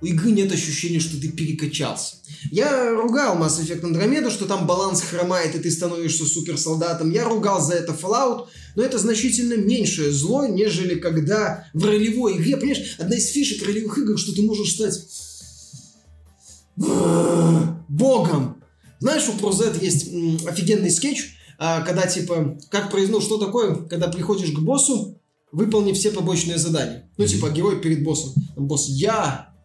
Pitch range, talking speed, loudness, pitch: 160-215 Hz, 150 wpm, -21 LUFS, 175 Hz